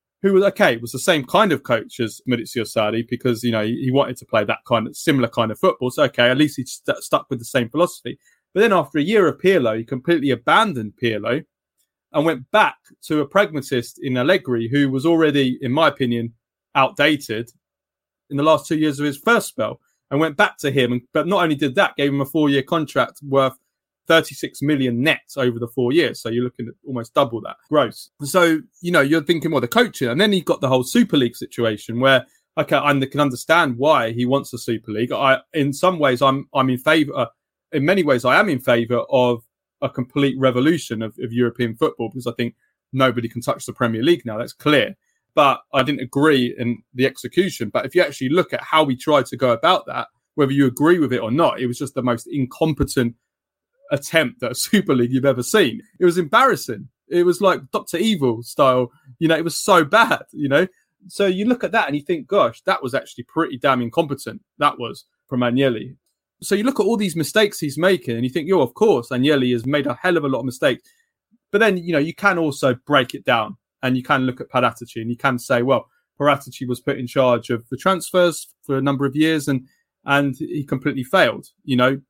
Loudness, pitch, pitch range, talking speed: -19 LUFS, 140 Hz, 125-160 Hz, 225 wpm